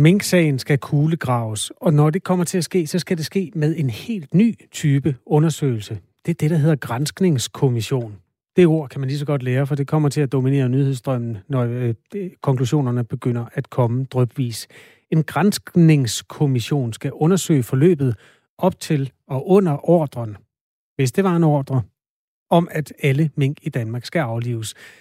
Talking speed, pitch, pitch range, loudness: 170 wpm, 145 Hz, 130-165 Hz, -20 LUFS